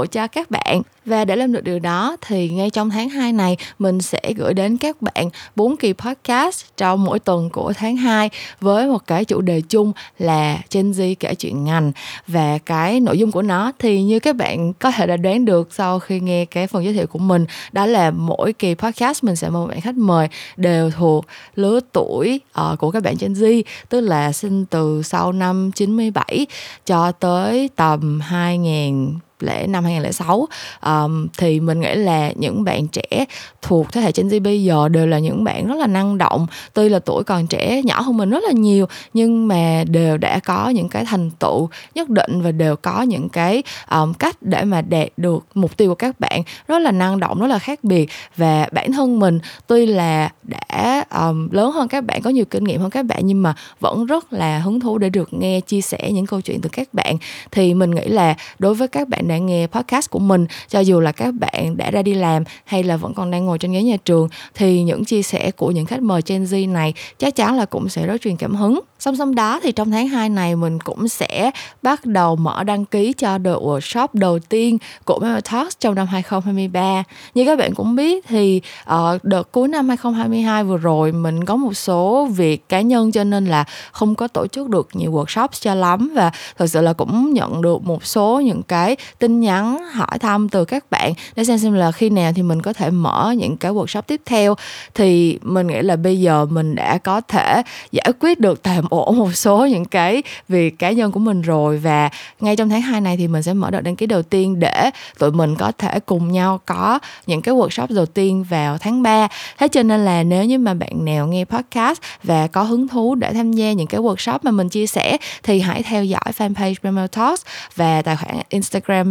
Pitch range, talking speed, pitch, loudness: 170-225 Hz, 225 wpm, 195 Hz, -17 LUFS